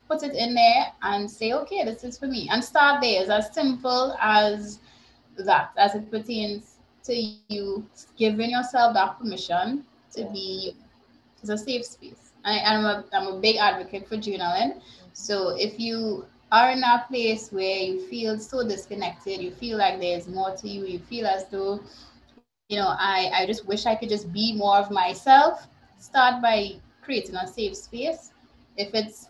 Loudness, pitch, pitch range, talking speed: -24 LUFS, 215 Hz, 195-240 Hz, 180 wpm